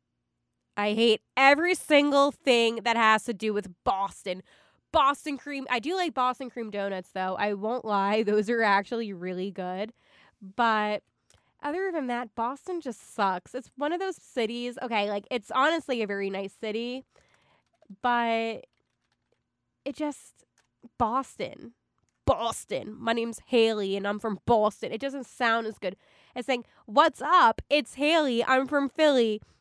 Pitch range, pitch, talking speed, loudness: 210-270 Hz, 235 Hz, 150 wpm, -27 LUFS